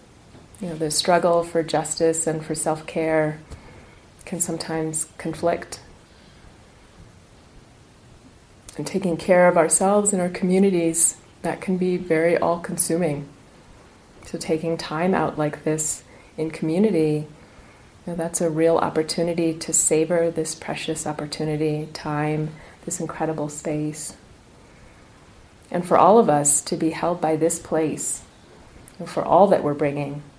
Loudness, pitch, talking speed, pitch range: -22 LUFS, 160 Hz, 130 wpm, 155-170 Hz